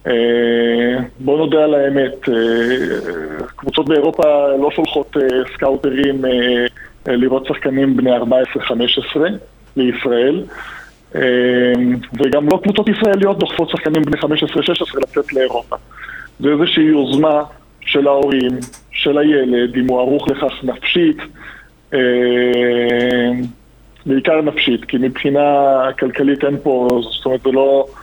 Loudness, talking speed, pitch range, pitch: -15 LUFS, 105 wpm, 125-145 Hz, 135 Hz